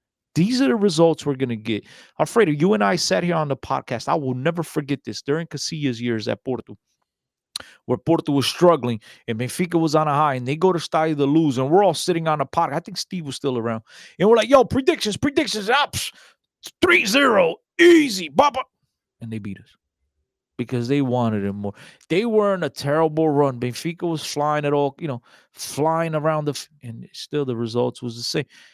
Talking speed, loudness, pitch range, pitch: 205 wpm, -21 LUFS, 125-170 Hz, 150 Hz